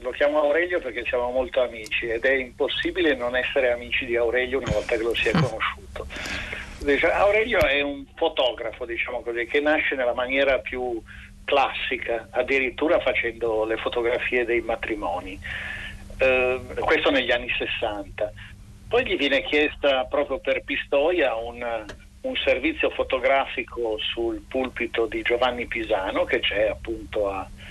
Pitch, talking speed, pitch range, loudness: 125 Hz, 135 wpm, 115-140 Hz, -24 LUFS